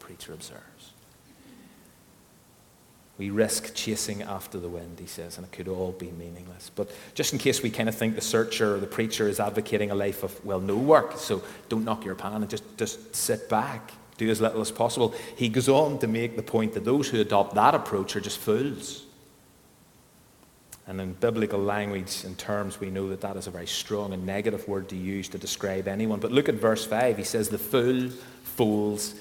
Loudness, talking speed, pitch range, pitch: -27 LUFS, 205 wpm, 95-115 Hz, 105 Hz